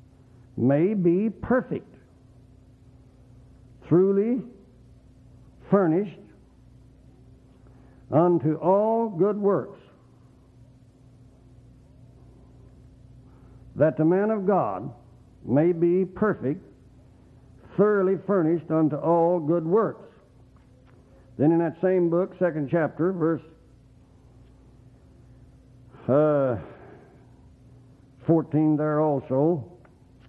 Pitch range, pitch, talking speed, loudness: 125-170 Hz, 130 Hz, 70 wpm, -24 LUFS